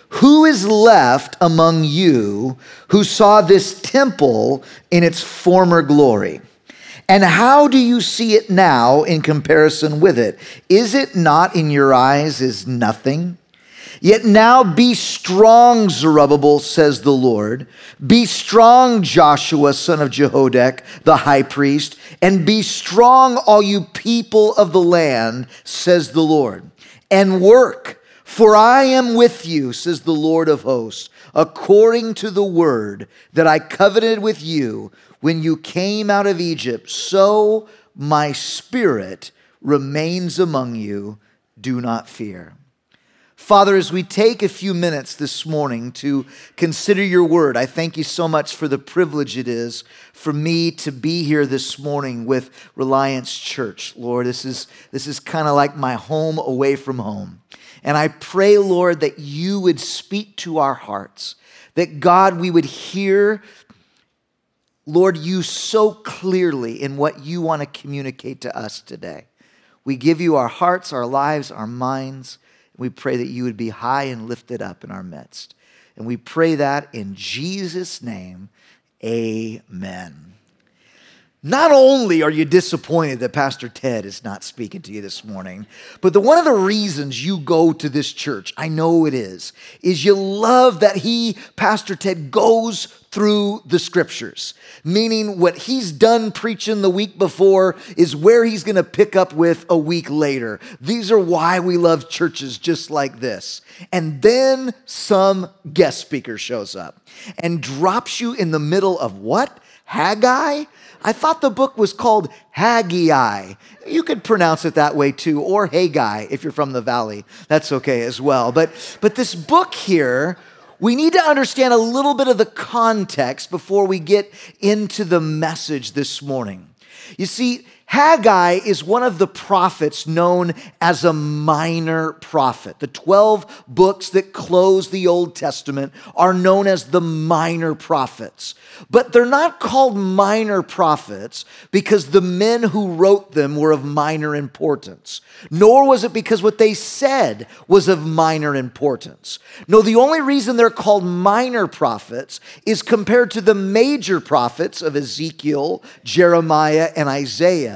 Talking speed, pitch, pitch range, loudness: 155 wpm, 170 Hz, 145-210 Hz, -15 LUFS